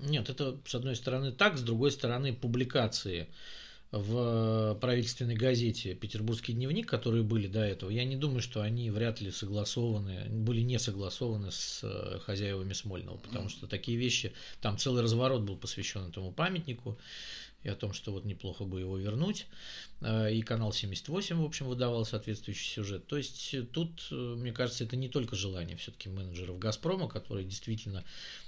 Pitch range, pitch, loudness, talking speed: 100-125 Hz, 115 Hz, -35 LUFS, 160 wpm